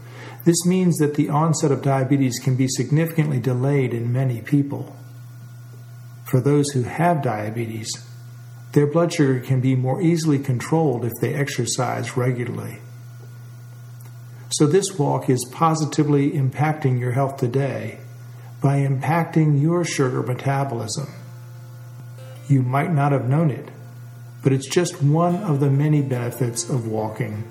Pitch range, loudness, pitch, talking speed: 120-145 Hz, -21 LUFS, 130 Hz, 135 wpm